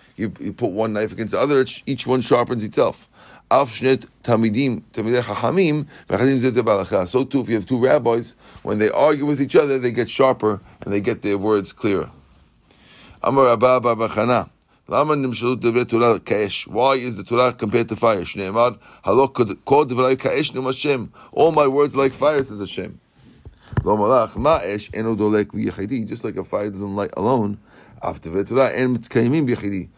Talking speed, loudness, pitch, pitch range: 110 wpm, -20 LUFS, 120 Hz, 105-130 Hz